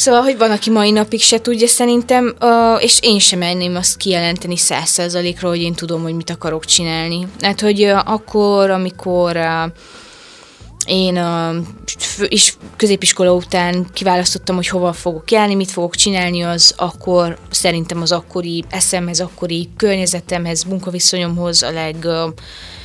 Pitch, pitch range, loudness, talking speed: 180 Hz, 170-205 Hz, -14 LUFS, 145 wpm